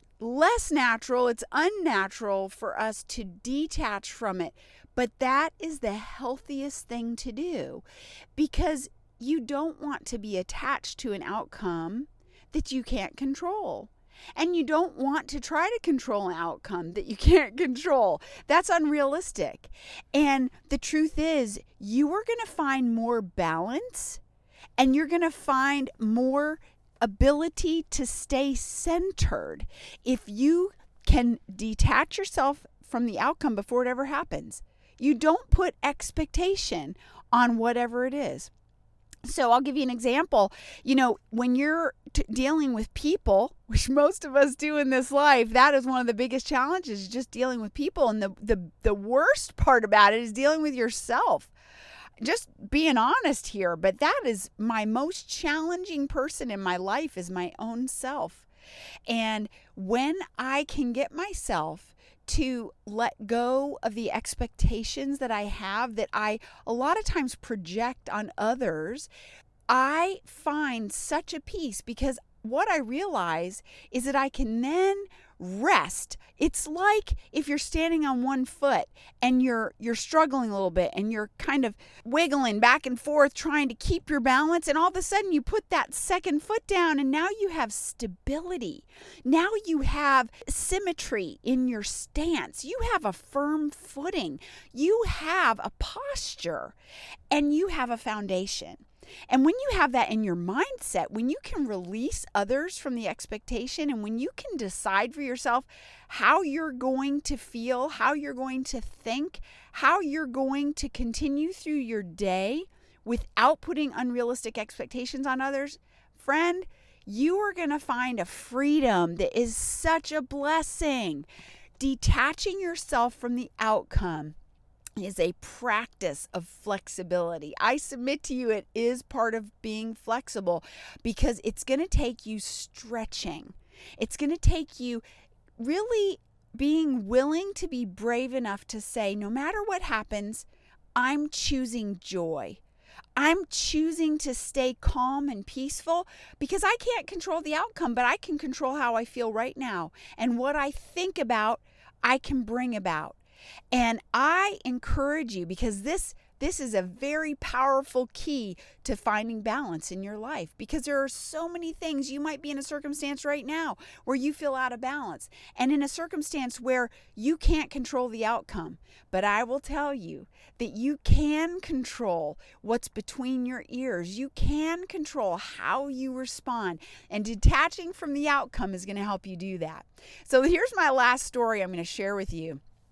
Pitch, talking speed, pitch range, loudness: 265 Hz, 160 wpm, 230-310 Hz, -28 LUFS